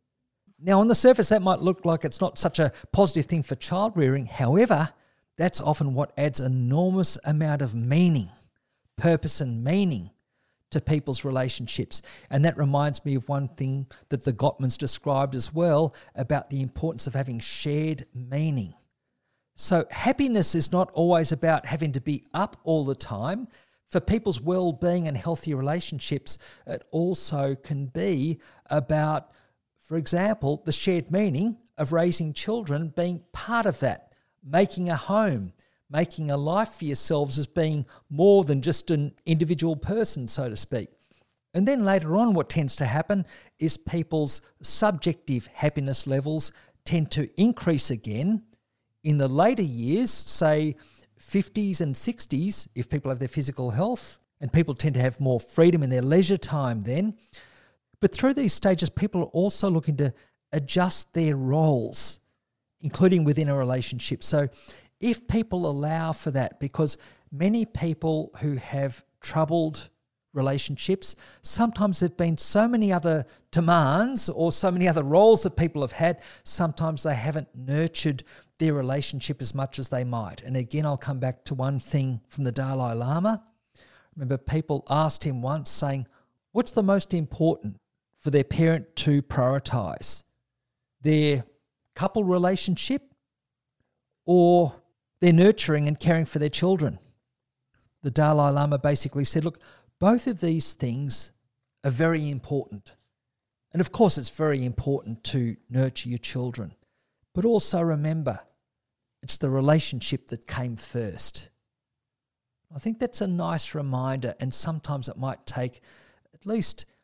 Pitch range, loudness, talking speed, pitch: 130-170 Hz, -25 LUFS, 150 wpm, 150 Hz